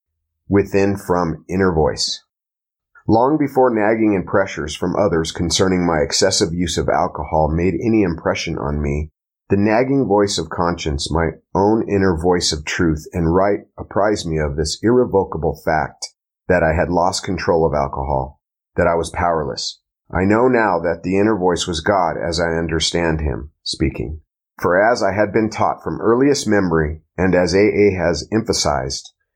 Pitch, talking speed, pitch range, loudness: 90 Hz, 165 wpm, 80-100 Hz, -18 LUFS